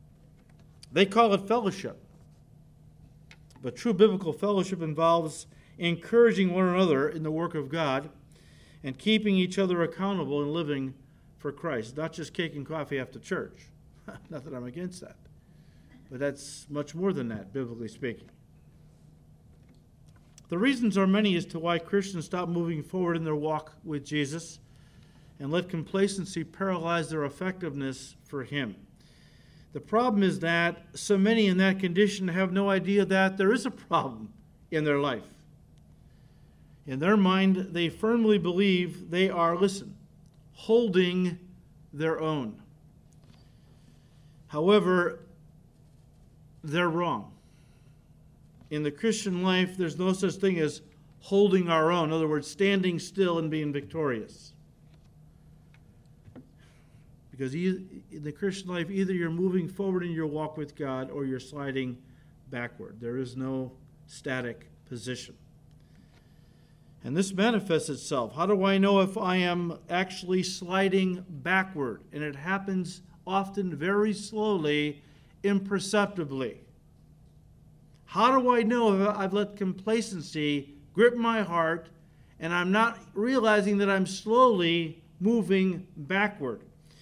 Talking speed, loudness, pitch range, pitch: 130 wpm, -28 LUFS, 150-195 Hz, 170 Hz